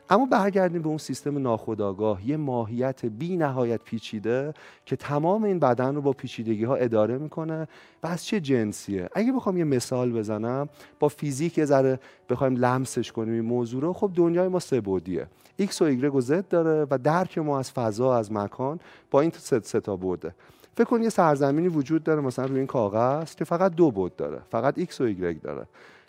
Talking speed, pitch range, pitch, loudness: 195 wpm, 120-170 Hz, 140 Hz, -26 LUFS